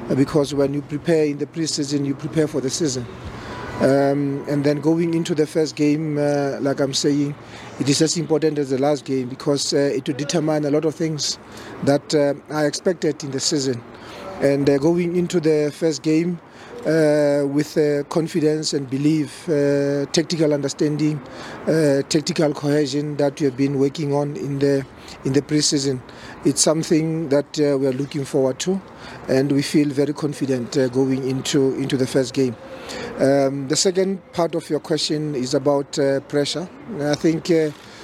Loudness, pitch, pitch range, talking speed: -20 LUFS, 145 Hz, 140-155 Hz, 180 wpm